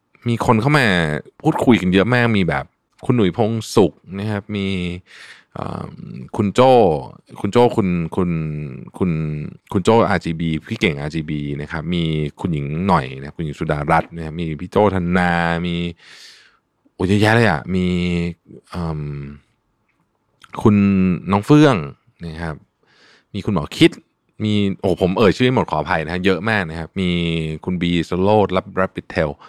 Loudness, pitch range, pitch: -18 LUFS, 80-100 Hz, 90 Hz